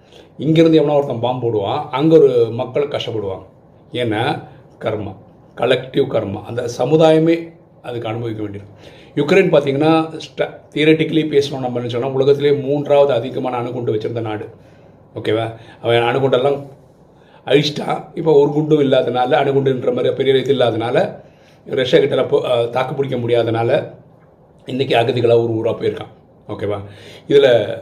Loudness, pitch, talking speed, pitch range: -16 LUFS, 140 Hz, 110 wpm, 120-155 Hz